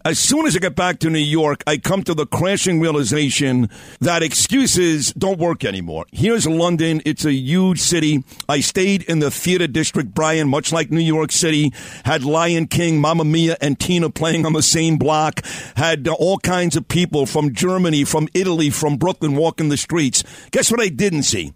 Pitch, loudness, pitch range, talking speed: 160 Hz, -17 LUFS, 145-175 Hz, 190 wpm